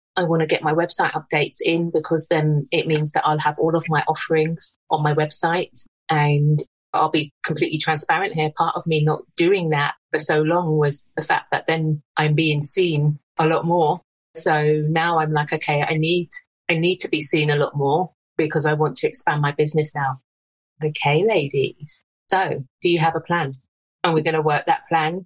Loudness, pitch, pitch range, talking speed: -20 LUFS, 155 Hz, 150-165 Hz, 205 wpm